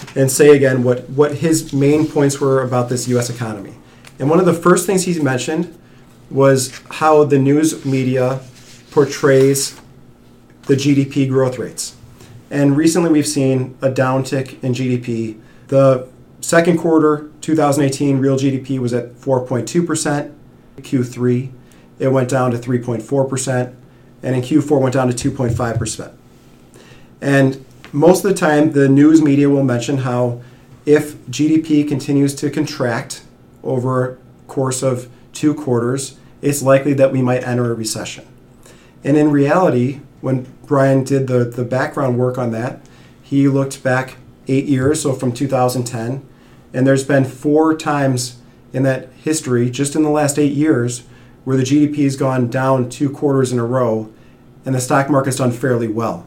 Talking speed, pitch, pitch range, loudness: 155 wpm, 135 Hz, 125-145 Hz, -16 LUFS